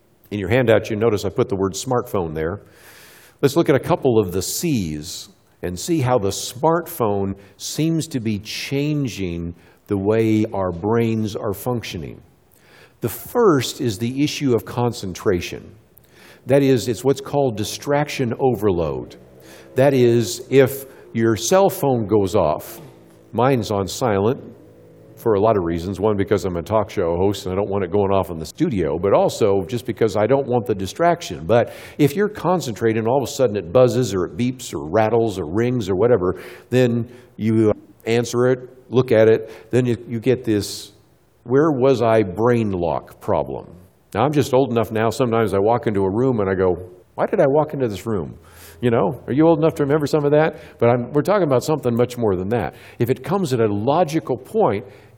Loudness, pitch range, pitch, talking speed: -20 LUFS, 100-130 Hz, 115 Hz, 190 wpm